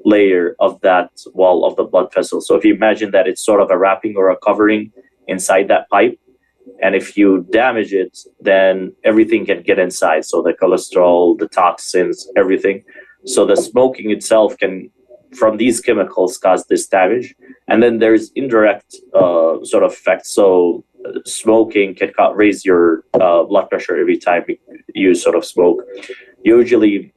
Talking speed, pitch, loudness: 165 wpm, 285 Hz, -14 LUFS